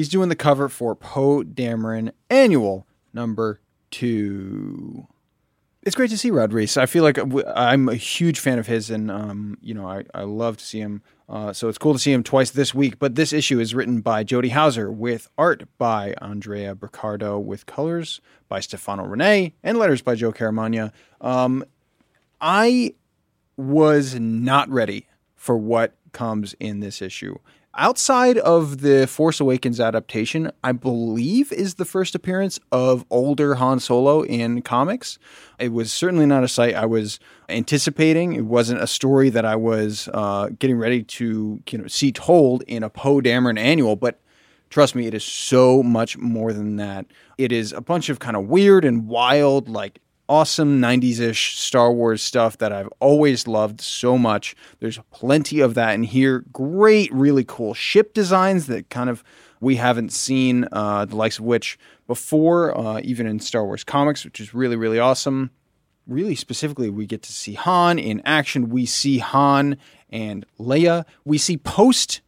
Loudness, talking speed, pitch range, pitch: -20 LUFS, 175 wpm, 110-145 Hz, 125 Hz